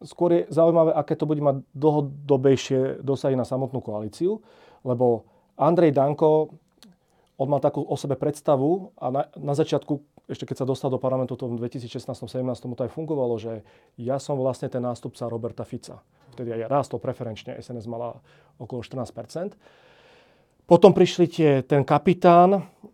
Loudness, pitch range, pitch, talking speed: -23 LUFS, 125-155 Hz, 135 Hz, 155 wpm